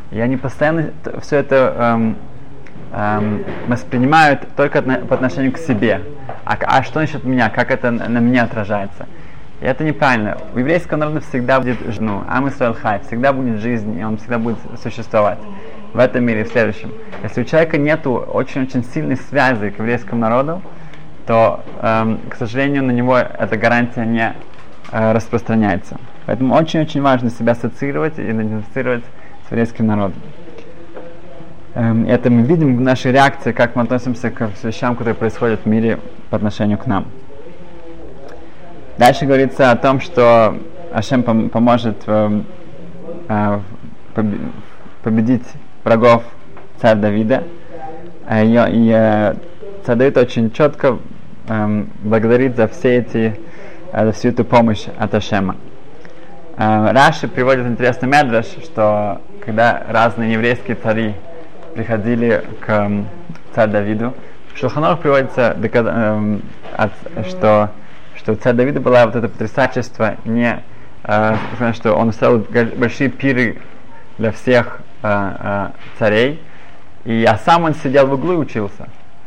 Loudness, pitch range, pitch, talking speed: -16 LUFS, 110-135 Hz, 120 Hz, 125 wpm